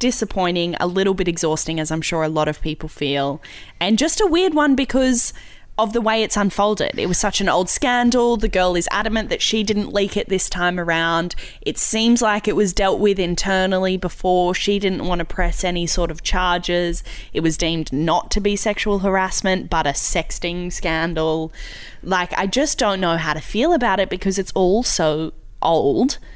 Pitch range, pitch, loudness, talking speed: 170-210 Hz, 185 Hz, -19 LUFS, 200 wpm